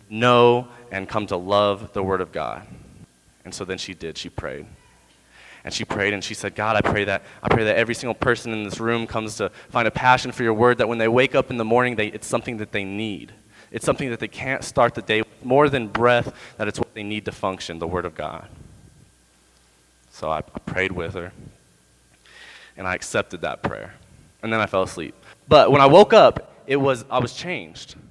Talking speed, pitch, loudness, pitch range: 225 wpm, 110 Hz, -21 LUFS, 95-120 Hz